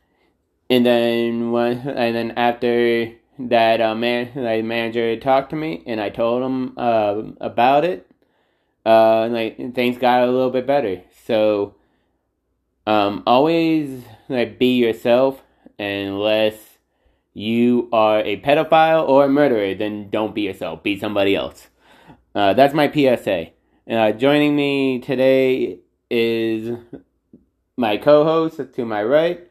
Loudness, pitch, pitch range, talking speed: -18 LUFS, 120 Hz, 110-135 Hz, 135 wpm